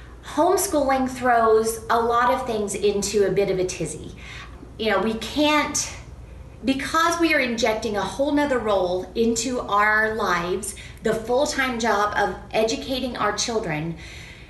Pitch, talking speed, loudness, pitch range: 220 Hz, 145 wpm, -22 LUFS, 200-260 Hz